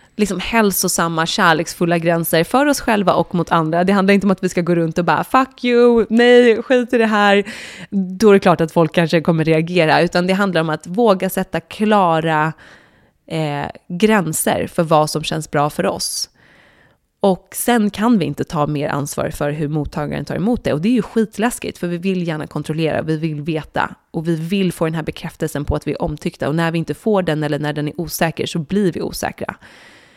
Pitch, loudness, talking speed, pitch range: 175 Hz, -17 LUFS, 215 wpm, 160-200 Hz